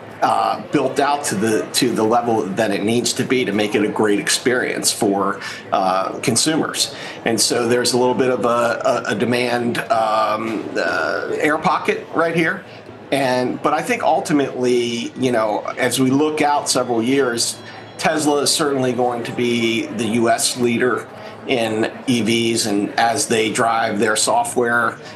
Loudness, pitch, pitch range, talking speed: -18 LUFS, 120 Hz, 115-130 Hz, 165 wpm